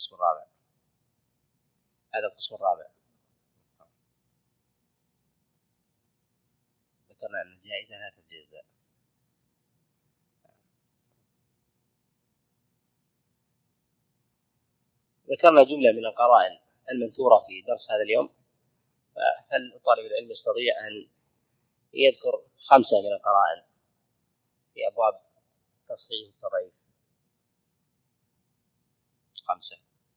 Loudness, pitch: -24 LUFS, 170 Hz